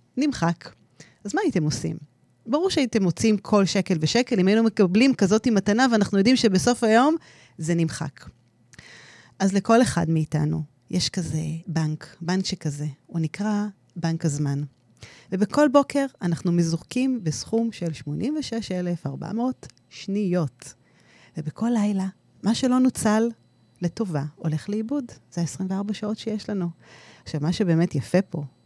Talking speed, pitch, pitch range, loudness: 130 wpm, 185 Hz, 155-220 Hz, -24 LUFS